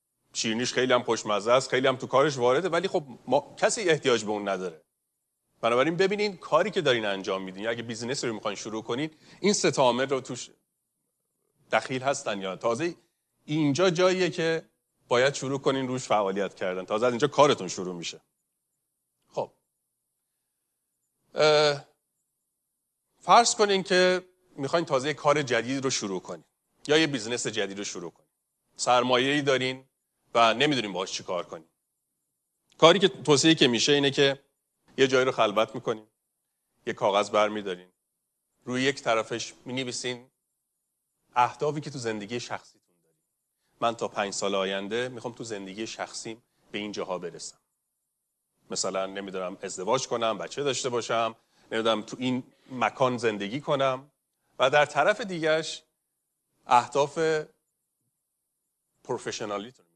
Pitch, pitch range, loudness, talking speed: 125 Hz, 110-150 Hz, -26 LUFS, 140 wpm